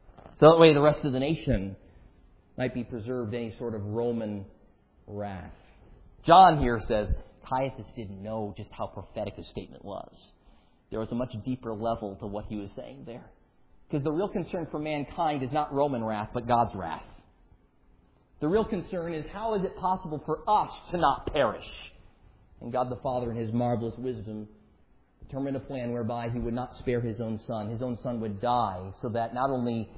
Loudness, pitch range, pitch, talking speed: -28 LUFS, 110-140 Hz, 120 Hz, 190 wpm